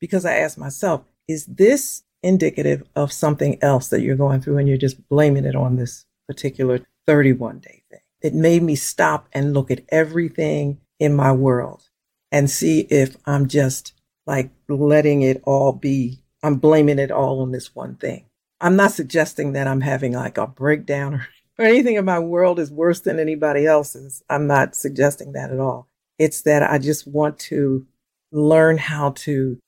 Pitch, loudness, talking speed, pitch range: 140 Hz, -19 LUFS, 180 wpm, 135-155 Hz